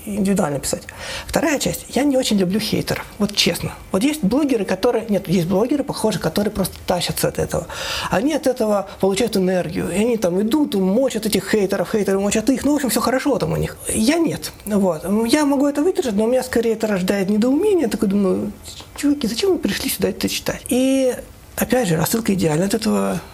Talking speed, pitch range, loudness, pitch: 200 wpm, 195-255 Hz, -19 LUFS, 220 Hz